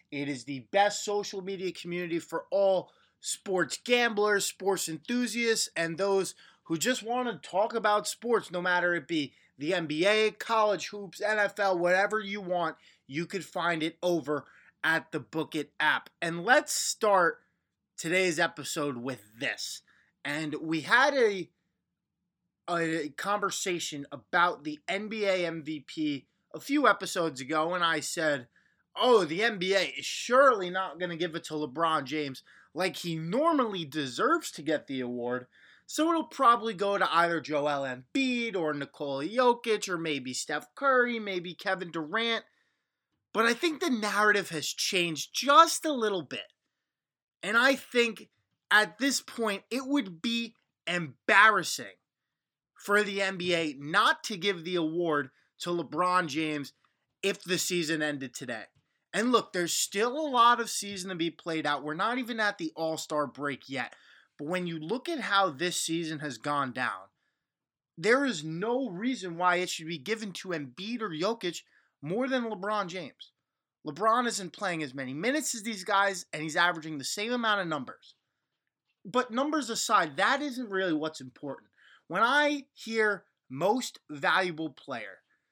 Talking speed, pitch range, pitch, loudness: 155 wpm, 160-220 Hz, 180 Hz, -29 LUFS